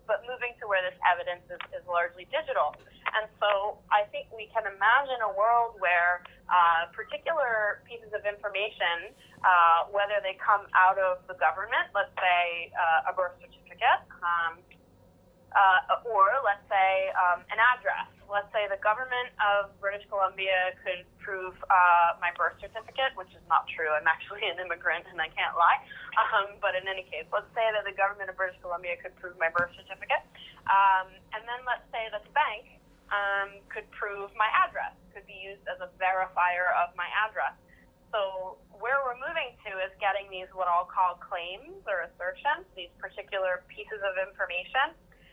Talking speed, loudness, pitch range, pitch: 175 wpm, -28 LUFS, 180-215 Hz, 195 Hz